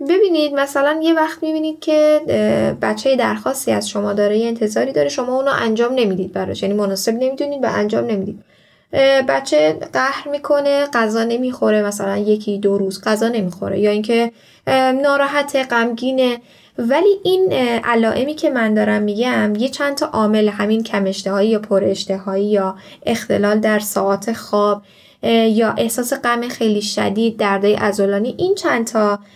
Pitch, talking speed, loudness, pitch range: 230 Hz, 145 wpm, -17 LUFS, 205-270 Hz